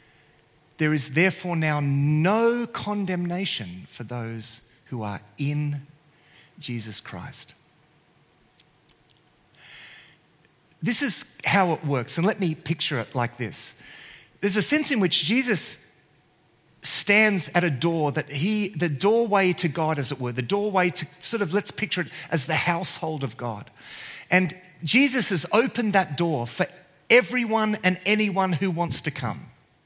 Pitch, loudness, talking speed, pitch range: 165 Hz, -22 LUFS, 145 wpm, 145-195 Hz